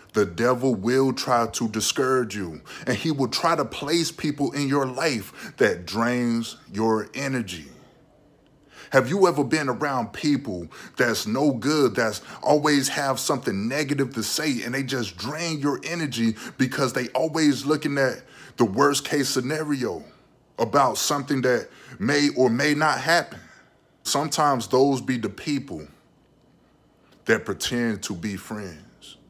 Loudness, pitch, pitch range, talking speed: -24 LUFS, 130 Hz, 115-145 Hz, 145 wpm